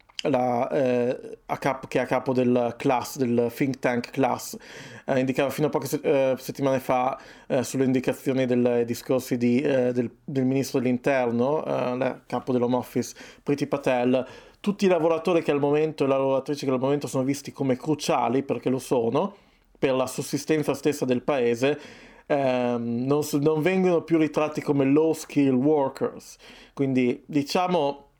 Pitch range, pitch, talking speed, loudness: 125-150 Hz, 135 Hz, 165 wpm, -25 LUFS